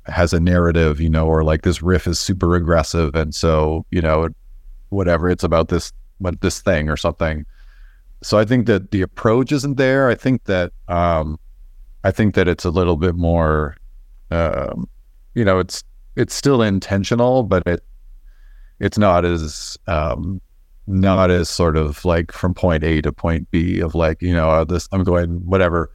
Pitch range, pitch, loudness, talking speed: 80-95 Hz, 85 Hz, -18 LUFS, 180 wpm